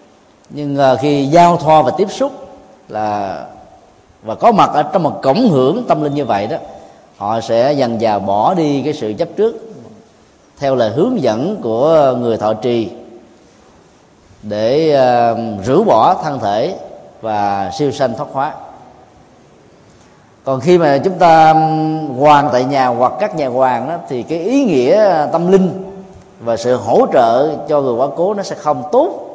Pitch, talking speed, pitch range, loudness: 145 Hz, 165 wpm, 120-165 Hz, -13 LUFS